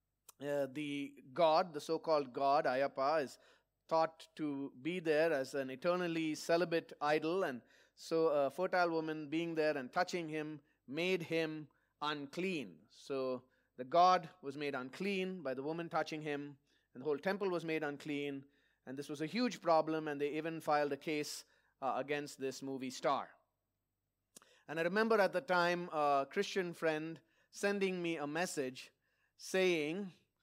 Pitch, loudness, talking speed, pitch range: 155 Hz, -37 LUFS, 160 wpm, 145-175 Hz